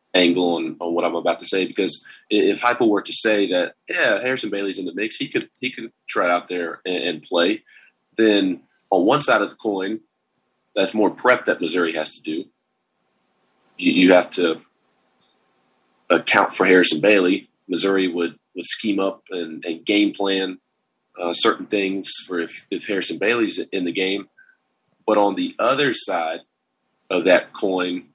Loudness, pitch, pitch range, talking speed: -20 LUFS, 95 Hz, 90-100 Hz, 175 wpm